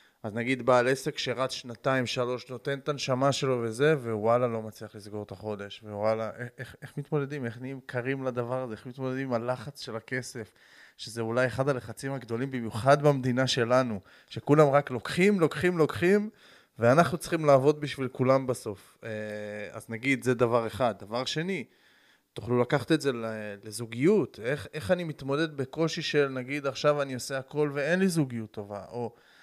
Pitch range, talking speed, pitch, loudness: 115-145 Hz, 165 wpm, 130 Hz, -28 LUFS